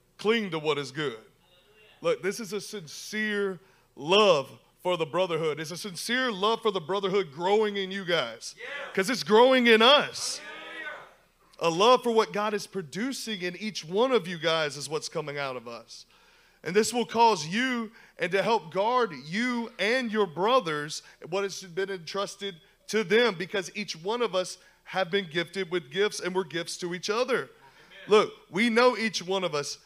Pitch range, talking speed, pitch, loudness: 180-225 Hz, 185 wpm, 200 Hz, -27 LUFS